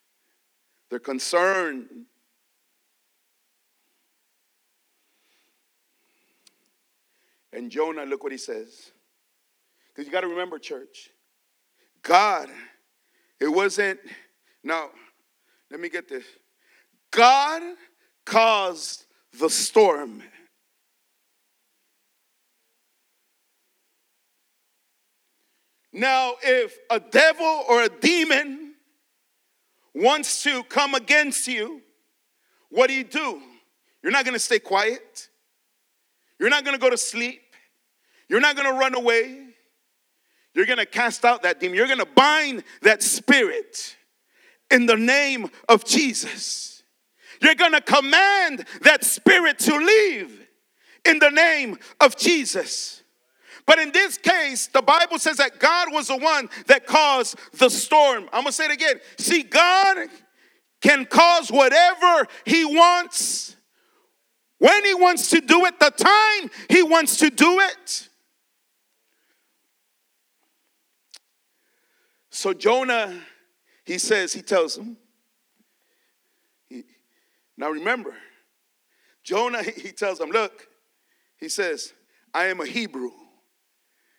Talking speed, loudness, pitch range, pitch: 110 wpm, -19 LUFS, 245-365 Hz, 300 Hz